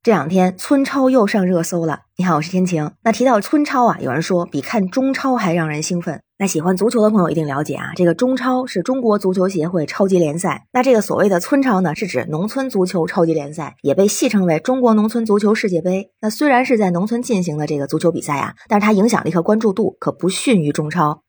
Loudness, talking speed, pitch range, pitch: -17 LUFS, 360 characters per minute, 165-230 Hz, 185 Hz